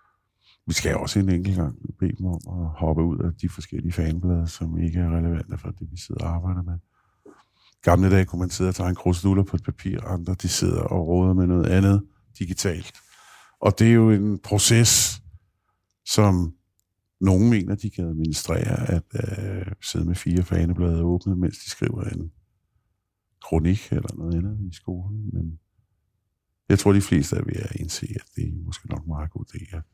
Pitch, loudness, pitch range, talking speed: 95 Hz, -23 LUFS, 85-100 Hz, 185 wpm